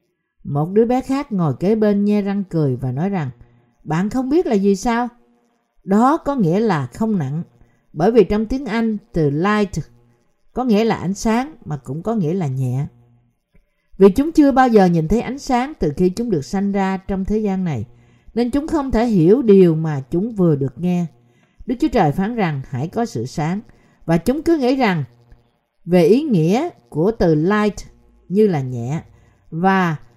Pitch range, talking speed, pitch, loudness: 150-225 Hz, 195 wpm, 190 Hz, -18 LUFS